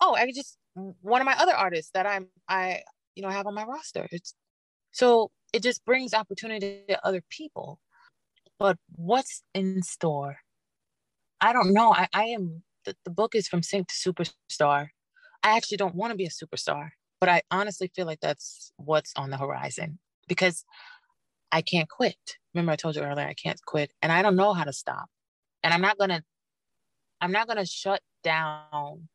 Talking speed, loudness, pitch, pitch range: 185 wpm, -27 LUFS, 185 Hz, 165-220 Hz